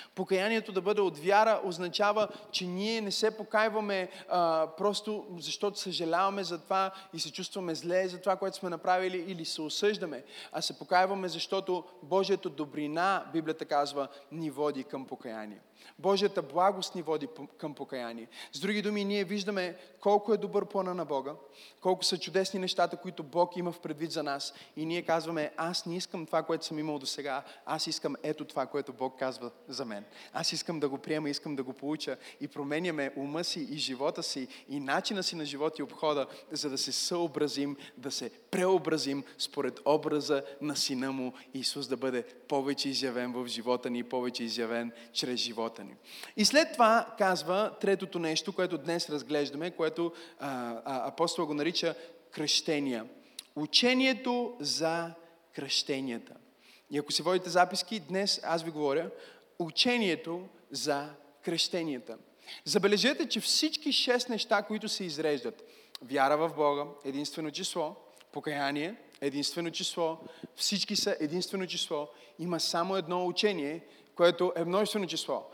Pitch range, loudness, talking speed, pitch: 145-190 Hz, -32 LUFS, 155 wpm, 165 Hz